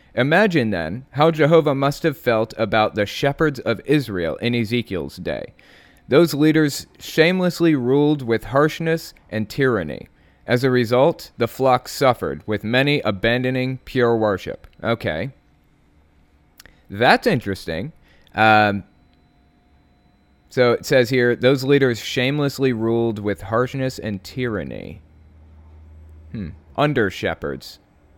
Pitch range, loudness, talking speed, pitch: 100-140 Hz, -19 LUFS, 115 wpm, 120 Hz